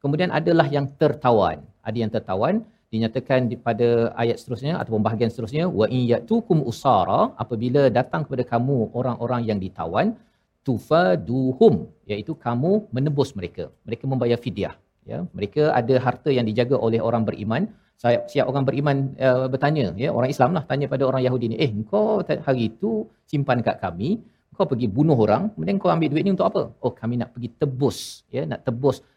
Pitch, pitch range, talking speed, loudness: 130 Hz, 115-150 Hz, 165 wpm, -22 LUFS